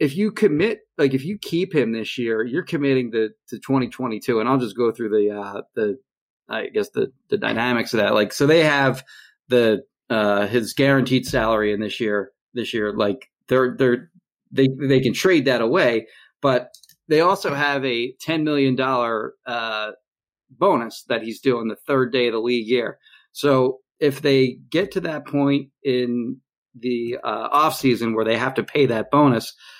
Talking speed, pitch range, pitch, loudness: 180 wpm, 115-140 Hz, 130 Hz, -21 LUFS